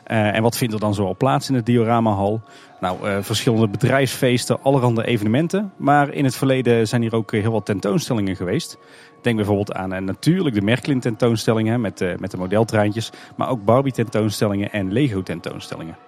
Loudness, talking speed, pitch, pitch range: -20 LUFS, 170 wpm, 115 Hz, 105-130 Hz